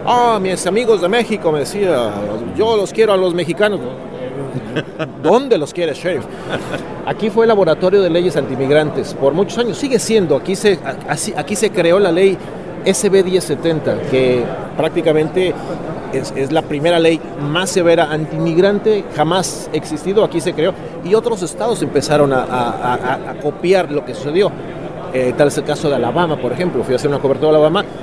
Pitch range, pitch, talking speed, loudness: 150-195 Hz, 170 Hz, 175 wpm, -16 LUFS